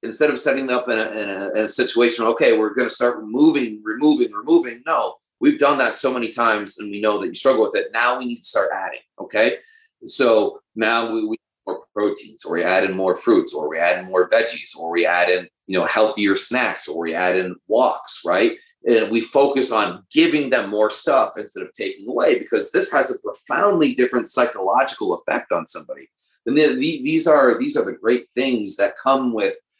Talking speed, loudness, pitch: 210 wpm, -19 LUFS, 125 Hz